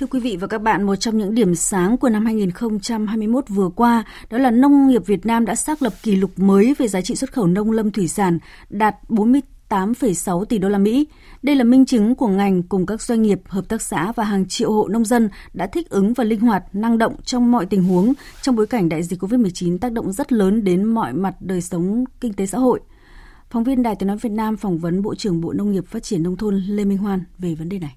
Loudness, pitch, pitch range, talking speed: -19 LUFS, 215 Hz, 190-235 Hz, 255 wpm